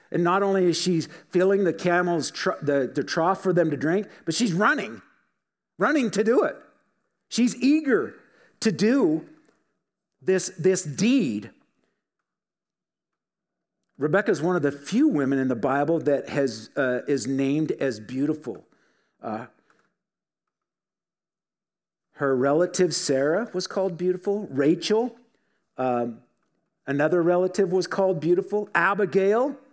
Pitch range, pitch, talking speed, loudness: 145-200 Hz, 180 Hz, 125 wpm, -24 LUFS